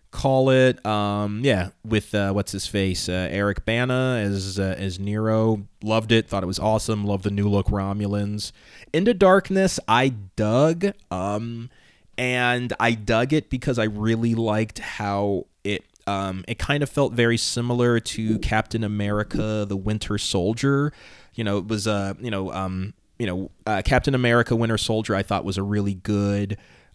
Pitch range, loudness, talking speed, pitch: 100-120 Hz, -23 LUFS, 170 wpm, 110 Hz